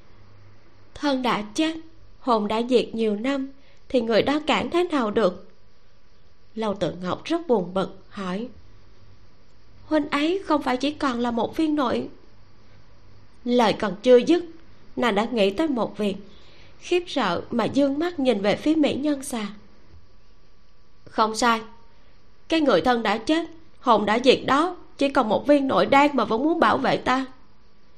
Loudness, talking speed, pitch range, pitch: -23 LUFS, 165 wpm, 180-280 Hz, 230 Hz